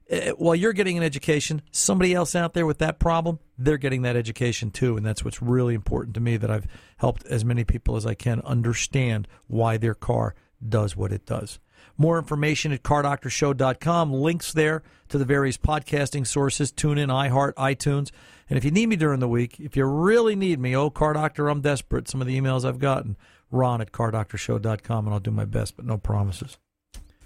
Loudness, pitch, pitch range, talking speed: -24 LUFS, 130 Hz, 115-150 Hz, 200 wpm